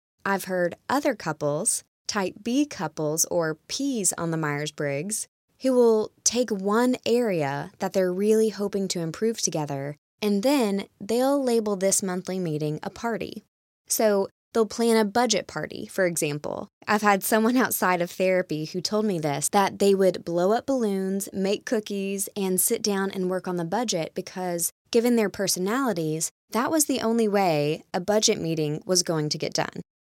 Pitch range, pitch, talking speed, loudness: 170-220 Hz, 195 Hz, 170 wpm, -25 LUFS